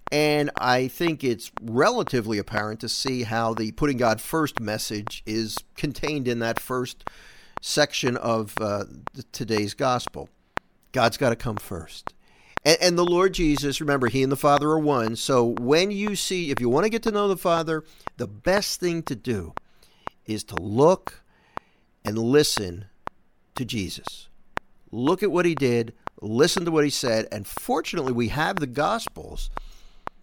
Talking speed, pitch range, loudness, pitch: 165 wpm, 115-155 Hz, -24 LUFS, 130 Hz